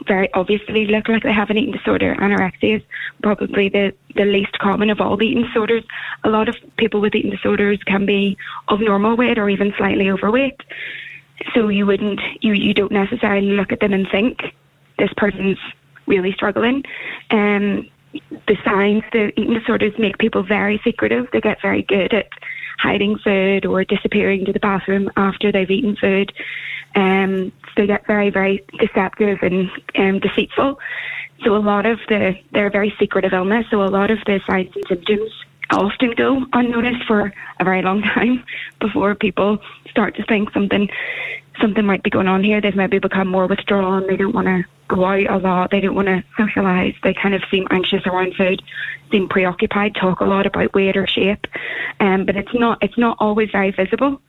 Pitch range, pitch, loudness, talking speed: 195-220 Hz, 205 Hz, -18 LUFS, 190 wpm